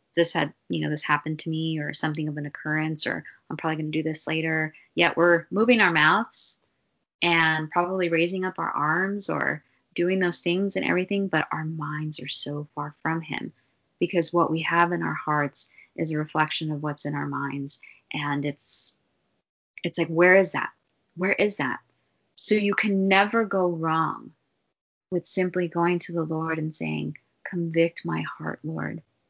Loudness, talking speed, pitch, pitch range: -25 LUFS, 180 wpm, 160 Hz, 150-175 Hz